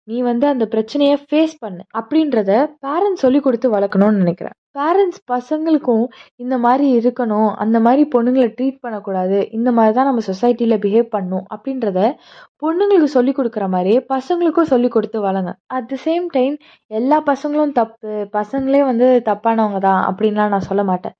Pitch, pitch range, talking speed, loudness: 245 Hz, 215-275 Hz, 150 wpm, -16 LUFS